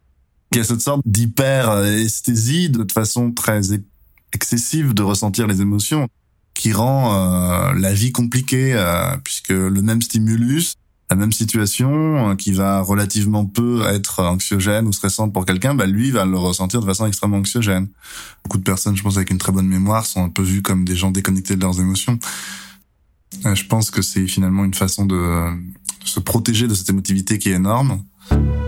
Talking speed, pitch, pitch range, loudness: 185 wpm, 100 Hz, 95-115 Hz, -18 LUFS